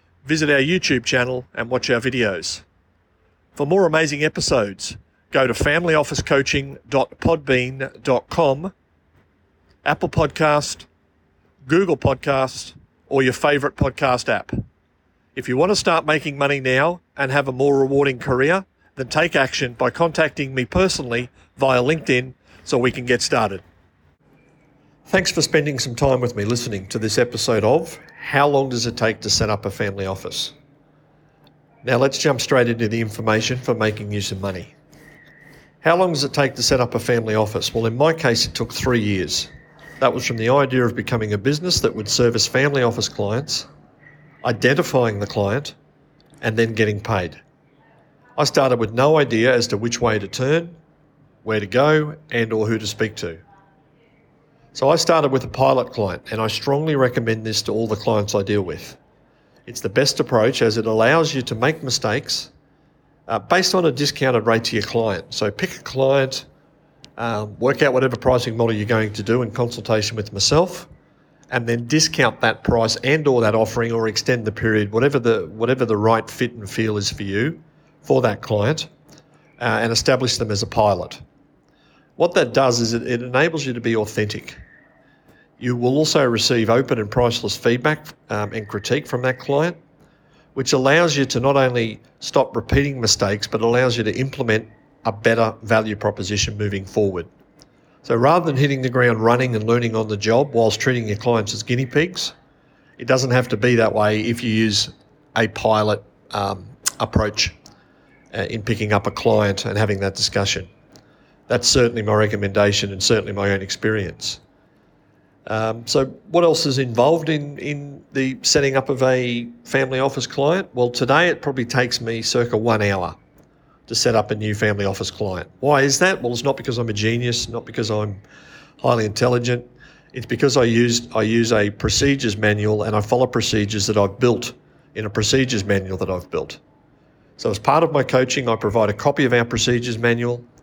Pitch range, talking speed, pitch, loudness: 110-140 Hz, 180 wpm, 120 Hz, -19 LUFS